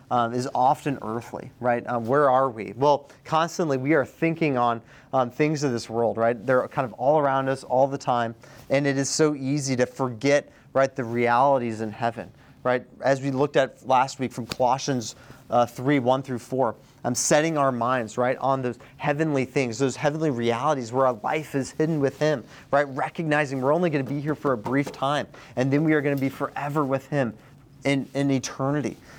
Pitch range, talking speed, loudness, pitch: 125-145 Hz, 210 wpm, -24 LUFS, 135 Hz